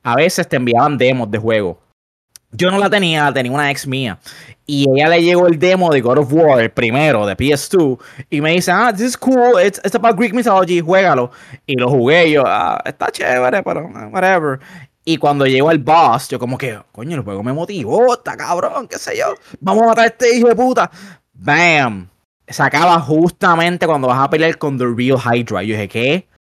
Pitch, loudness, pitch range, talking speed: 155 Hz, -14 LUFS, 130-185 Hz, 215 wpm